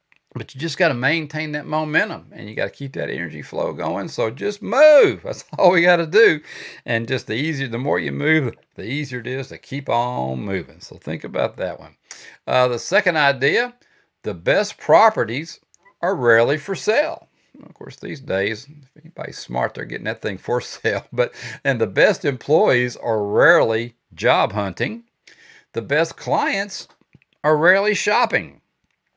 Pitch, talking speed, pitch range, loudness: 150 Hz, 175 wpm, 120-185 Hz, -19 LUFS